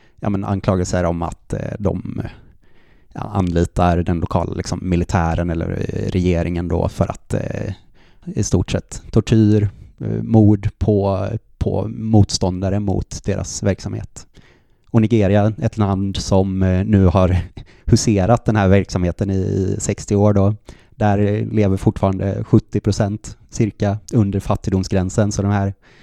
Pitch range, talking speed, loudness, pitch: 95-110 Hz, 120 wpm, -18 LUFS, 100 Hz